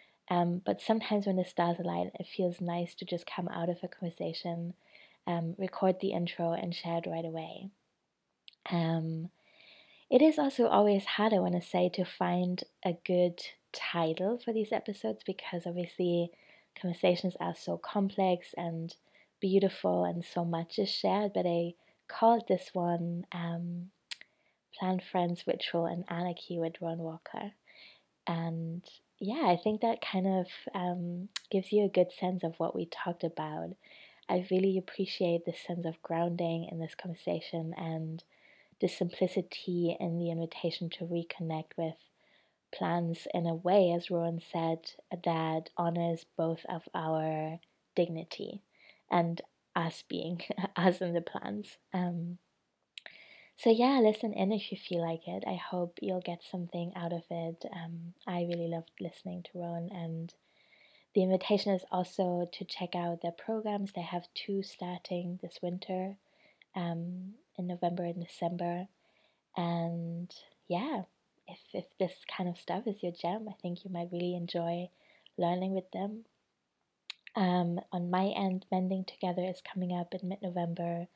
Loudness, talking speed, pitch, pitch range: -34 LUFS, 150 wpm, 175 Hz, 170-190 Hz